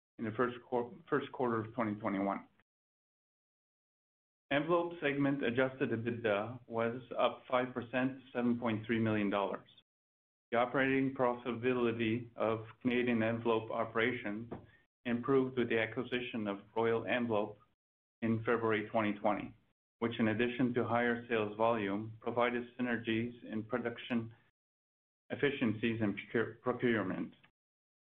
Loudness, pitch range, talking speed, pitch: -35 LUFS, 110-125 Hz, 100 wpm, 115 Hz